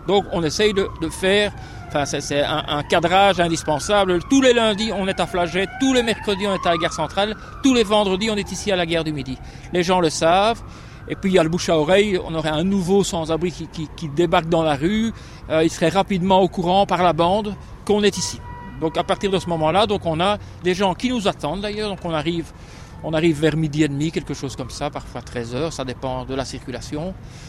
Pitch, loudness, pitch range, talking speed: 175 Hz, -20 LUFS, 155-195 Hz, 245 wpm